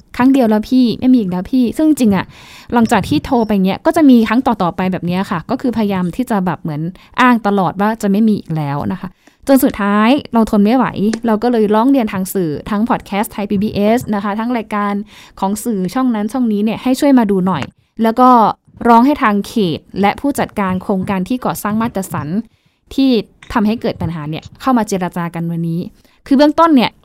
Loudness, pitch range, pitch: -14 LUFS, 190-240 Hz, 215 Hz